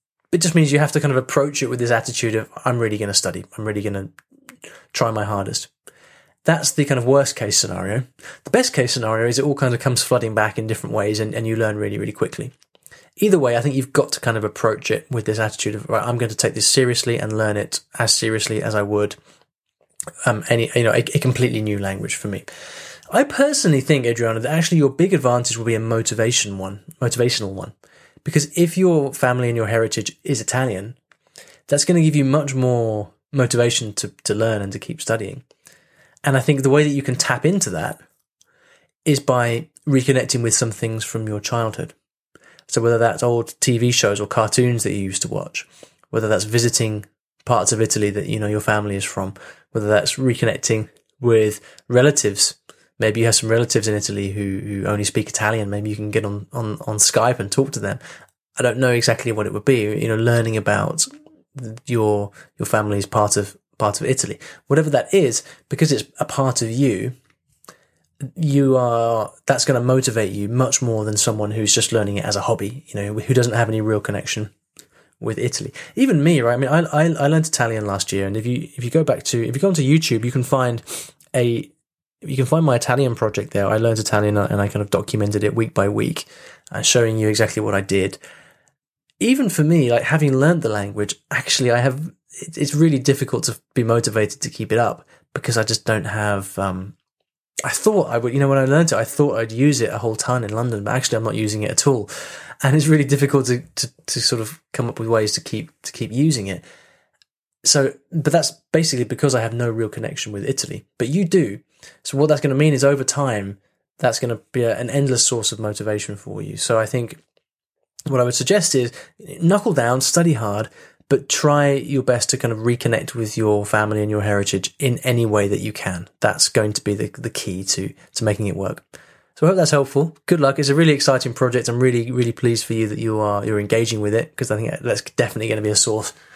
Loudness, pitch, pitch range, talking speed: -19 LUFS, 120 Hz, 110-140 Hz, 225 wpm